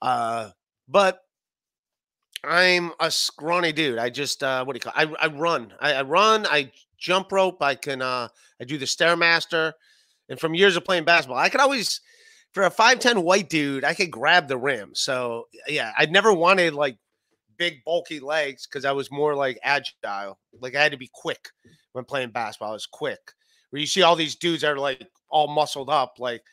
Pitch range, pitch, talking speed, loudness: 130-175 Hz, 155 Hz, 200 wpm, -22 LUFS